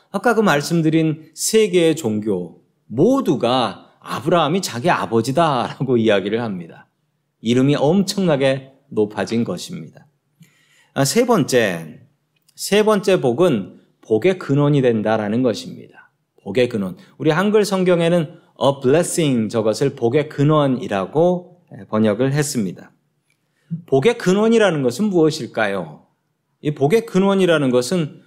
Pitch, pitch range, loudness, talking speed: 155 Hz, 130-180 Hz, -18 LUFS, 280 characters per minute